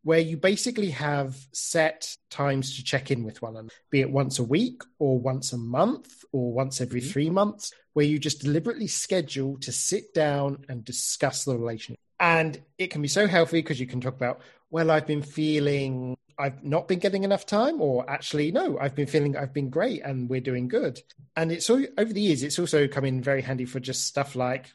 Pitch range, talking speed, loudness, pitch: 130-165 Hz, 215 wpm, -26 LUFS, 140 Hz